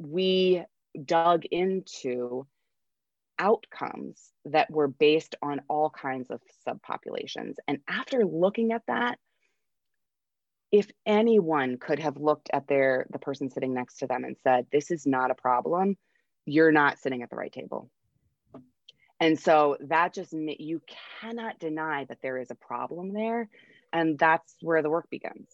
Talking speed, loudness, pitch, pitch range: 150 wpm, -27 LUFS, 155 Hz, 140-185 Hz